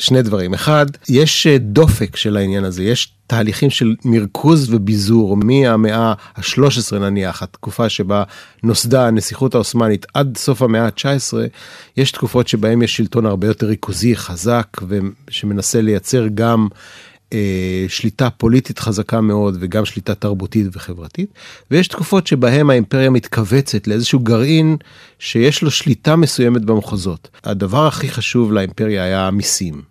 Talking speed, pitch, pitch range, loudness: 130 wpm, 115 Hz, 105-130 Hz, -15 LUFS